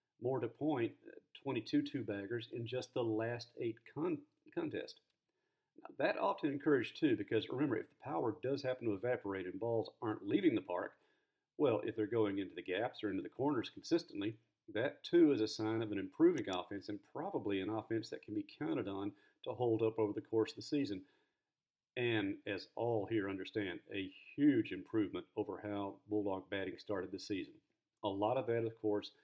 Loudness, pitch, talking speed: -39 LUFS, 125 Hz, 190 wpm